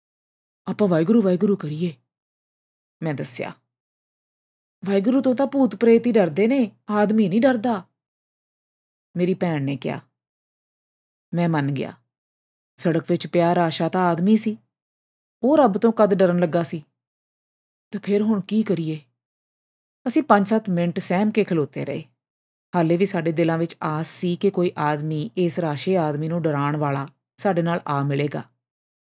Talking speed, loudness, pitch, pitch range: 140 wpm, -21 LUFS, 175 Hz, 150-205 Hz